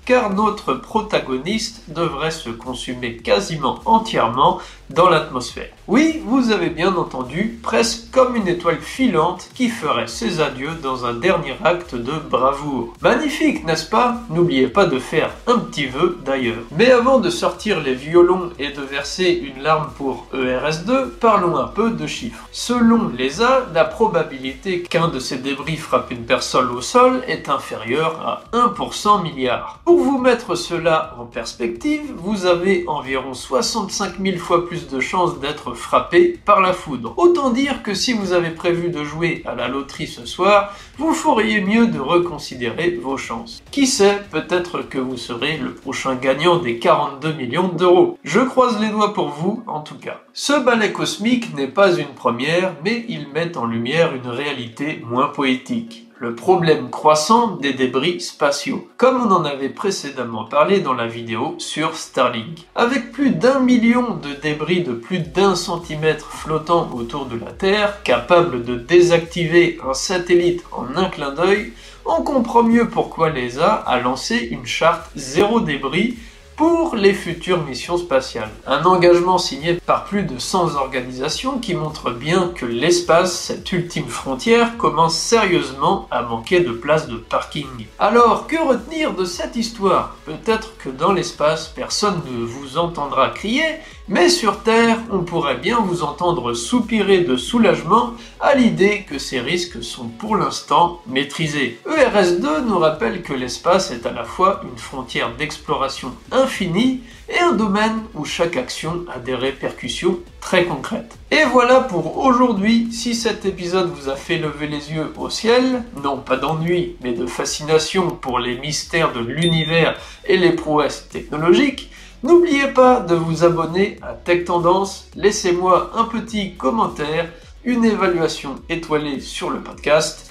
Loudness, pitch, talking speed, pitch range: -18 LUFS, 175 Hz, 160 wpm, 145-220 Hz